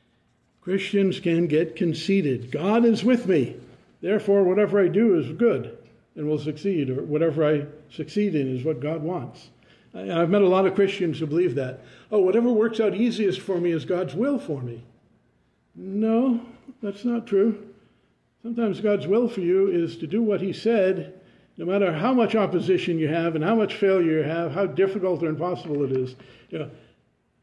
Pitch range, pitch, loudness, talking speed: 160-205 Hz, 185 Hz, -23 LUFS, 180 wpm